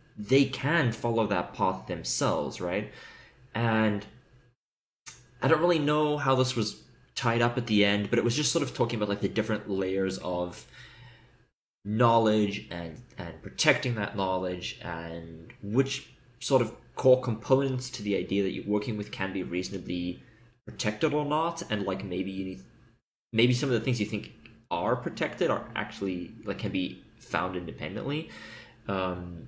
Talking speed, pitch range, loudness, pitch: 165 wpm, 95-125 Hz, -29 LUFS, 110 Hz